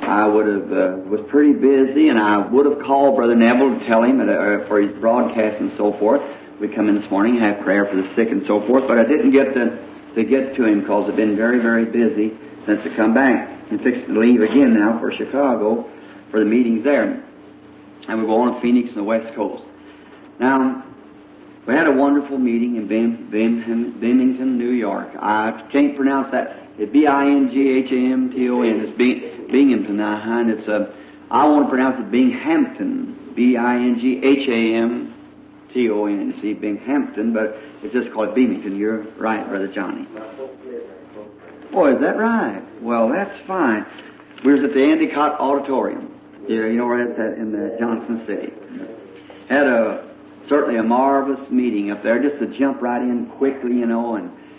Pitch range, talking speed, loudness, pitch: 110-135 Hz, 180 wpm, -18 LUFS, 120 Hz